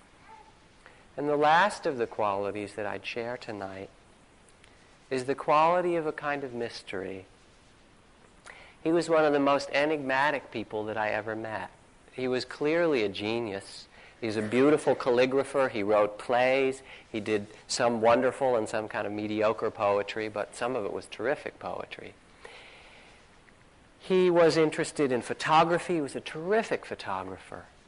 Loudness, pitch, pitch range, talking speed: -28 LUFS, 125 Hz, 110-150 Hz, 150 wpm